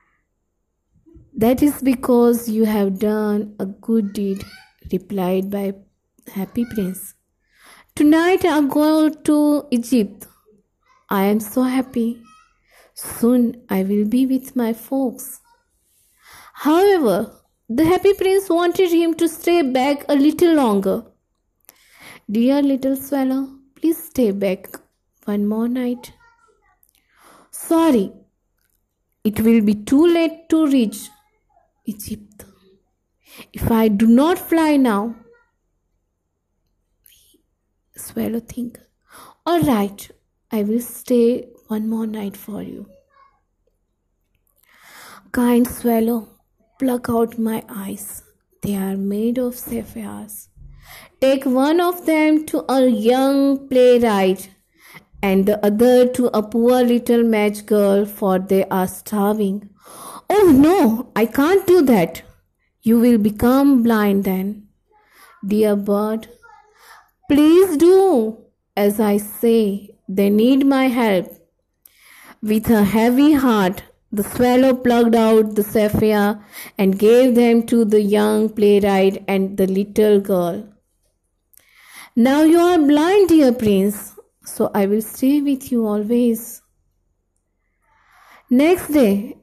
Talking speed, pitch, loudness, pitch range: 115 wpm, 230 Hz, -17 LUFS, 205-275 Hz